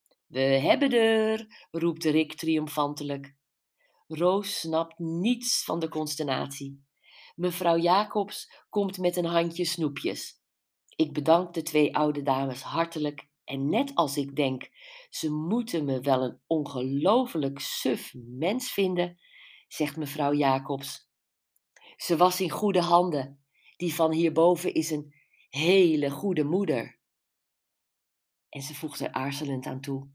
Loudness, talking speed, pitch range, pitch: -27 LUFS, 125 wpm, 140-175 Hz, 155 Hz